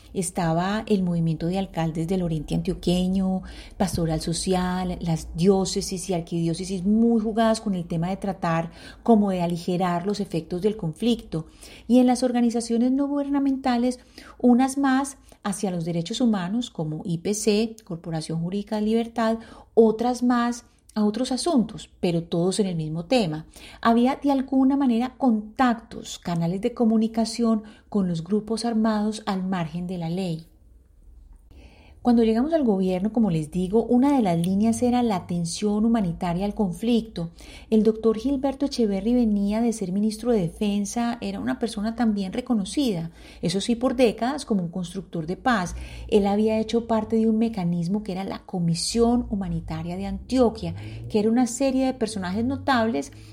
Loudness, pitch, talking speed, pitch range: -24 LUFS, 210 Hz, 155 wpm, 180-235 Hz